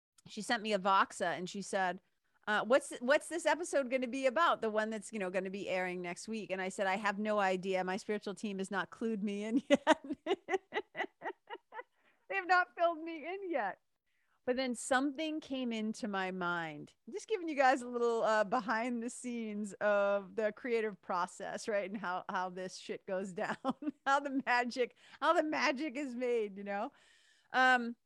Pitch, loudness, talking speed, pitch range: 230 Hz, -35 LUFS, 195 wpm, 200-290 Hz